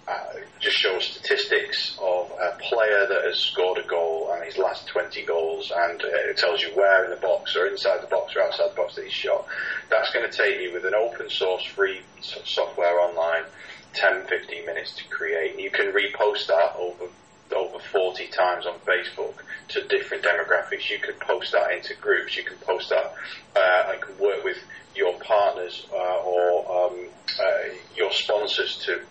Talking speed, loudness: 190 wpm, -24 LUFS